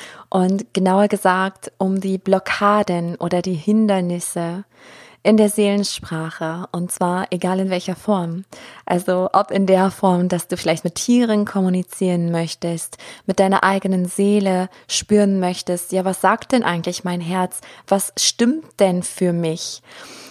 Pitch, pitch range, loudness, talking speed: 185 Hz, 180-195 Hz, -19 LUFS, 140 wpm